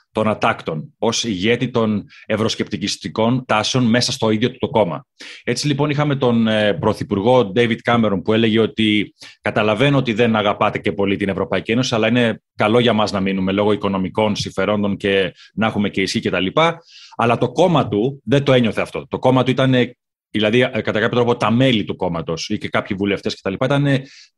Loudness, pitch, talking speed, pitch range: -18 LUFS, 110 Hz, 180 wpm, 105-125 Hz